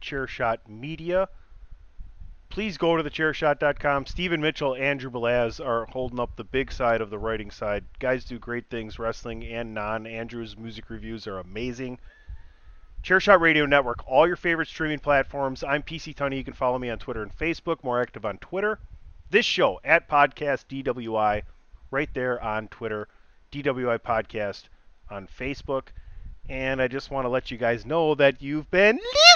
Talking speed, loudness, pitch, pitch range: 165 wpm, -25 LUFS, 130 Hz, 115-145 Hz